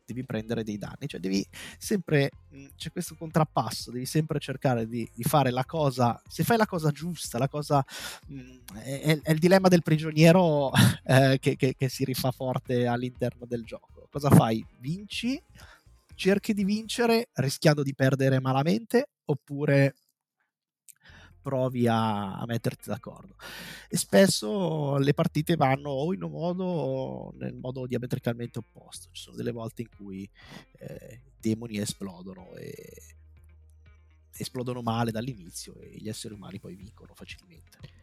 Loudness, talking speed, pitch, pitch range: -27 LUFS, 150 wpm, 130 Hz, 110-155 Hz